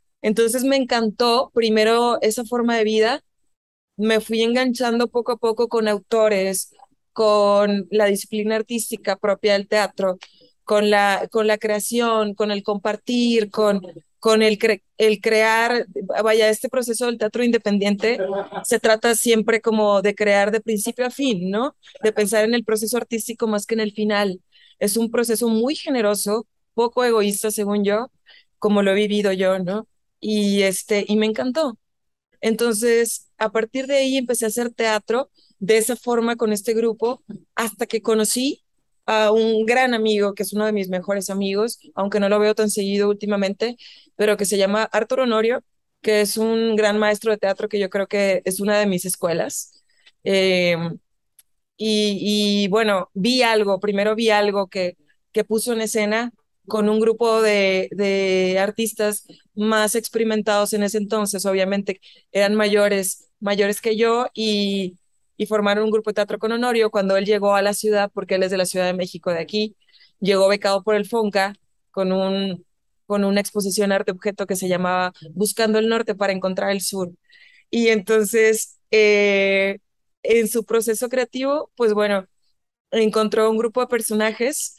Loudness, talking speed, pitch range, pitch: -20 LUFS, 165 wpm, 200-230 Hz, 215 Hz